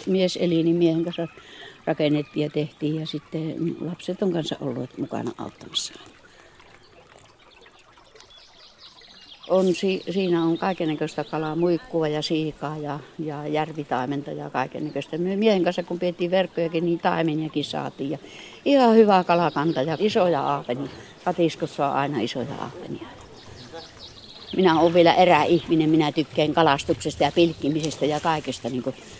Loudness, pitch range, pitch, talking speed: -23 LUFS, 150-175 Hz, 160 Hz, 130 wpm